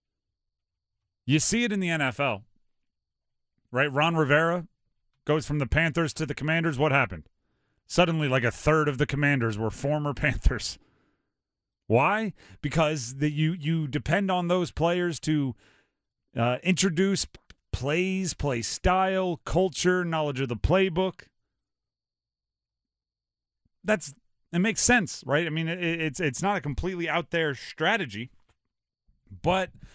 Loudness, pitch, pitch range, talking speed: -26 LUFS, 150 Hz, 125-175 Hz, 130 wpm